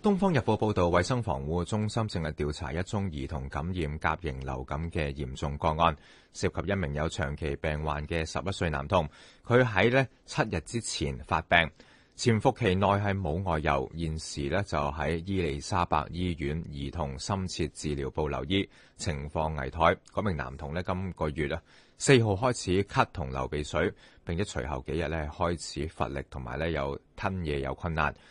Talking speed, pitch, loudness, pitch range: 265 characters per minute, 80 Hz, -30 LUFS, 75-95 Hz